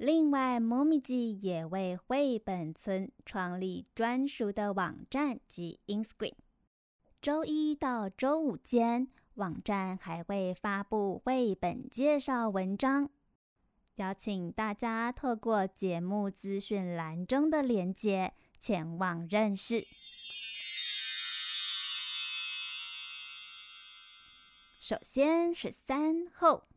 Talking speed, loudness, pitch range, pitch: 160 characters per minute, -32 LUFS, 175-255 Hz, 205 Hz